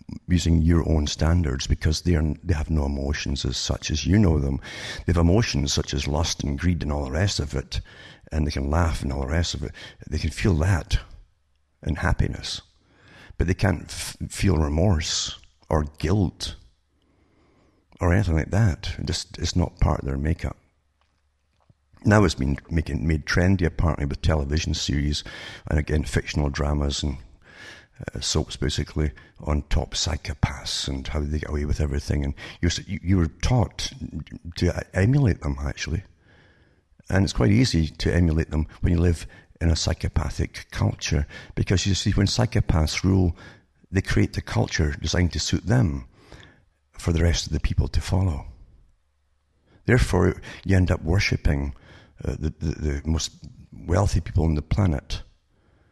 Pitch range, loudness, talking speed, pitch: 75-95 Hz, -24 LUFS, 165 wpm, 80 Hz